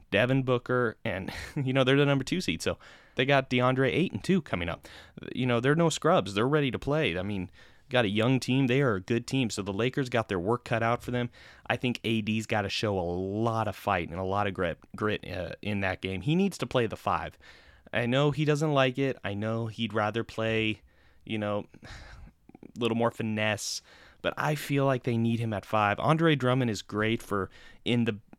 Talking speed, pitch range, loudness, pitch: 230 wpm, 105-130 Hz, -29 LUFS, 115 Hz